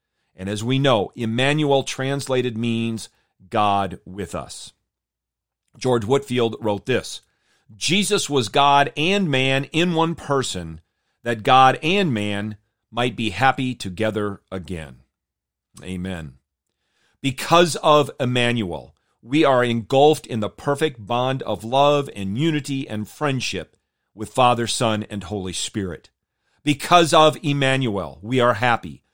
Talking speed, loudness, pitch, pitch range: 125 wpm, -20 LUFS, 120 Hz, 105-140 Hz